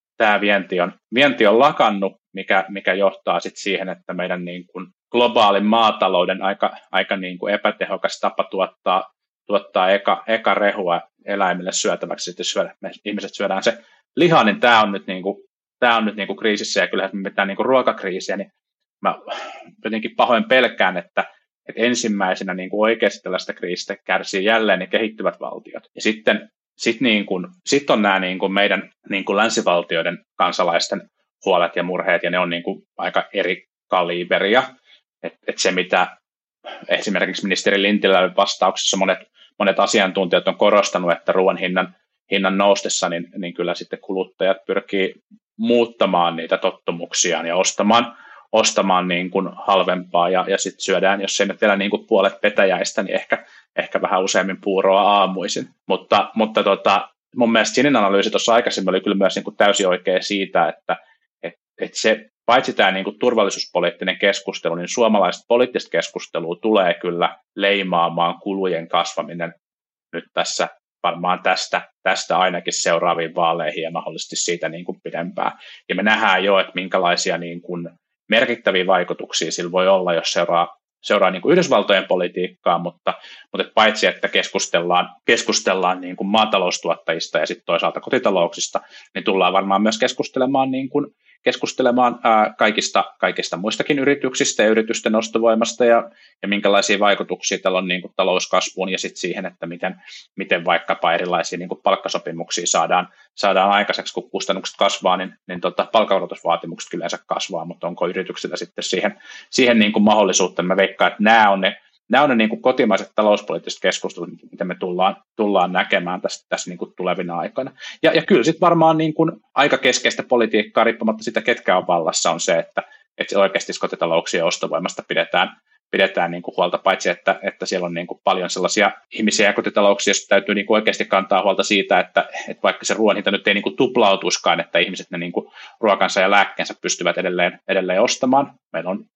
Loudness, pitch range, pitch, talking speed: -19 LUFS, 90-110 Hz, 100 Hz, 165 wpm